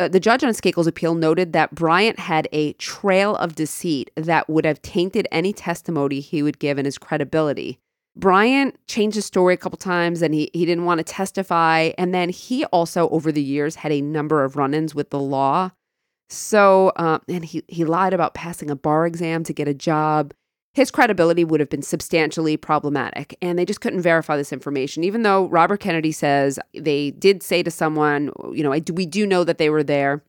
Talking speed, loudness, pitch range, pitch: 205 wpm, -20 LUFS, 150-185 Hz, 165 Hz